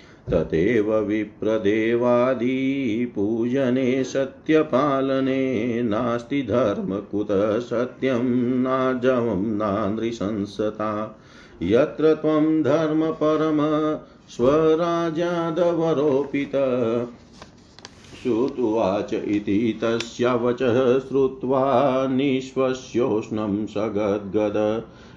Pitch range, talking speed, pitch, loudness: 110-135 Hz, 50 wpm, 125 Hz, -22 LUFS